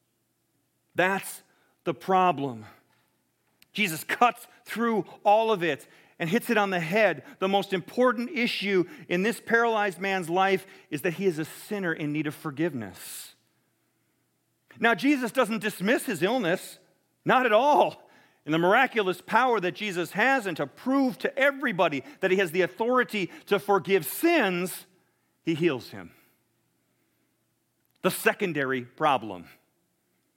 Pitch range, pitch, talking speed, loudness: 160-220 Hz, 185 Hz, 135 wpm, -26 LUFS